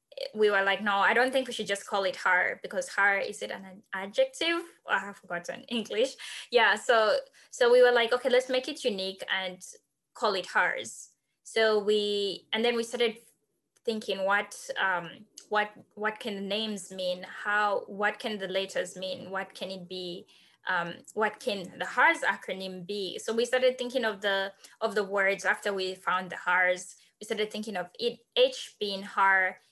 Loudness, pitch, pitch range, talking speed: -29 LUFS, 210 Hz, 190-240 Hz, 190 wpm